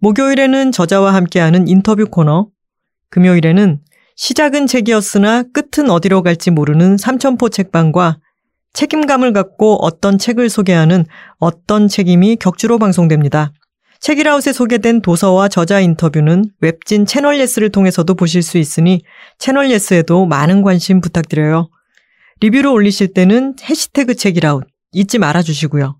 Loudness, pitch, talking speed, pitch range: -12 LUFS, 195 Hz, 335 characters per minute, 170-235 Hz